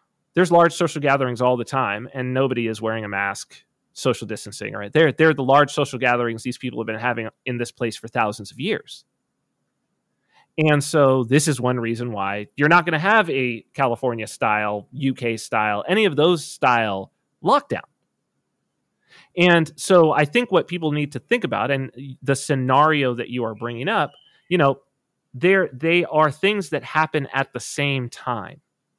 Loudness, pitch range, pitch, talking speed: -21 LUFS, 120-155 Hz, 135 Hz, 180 wpm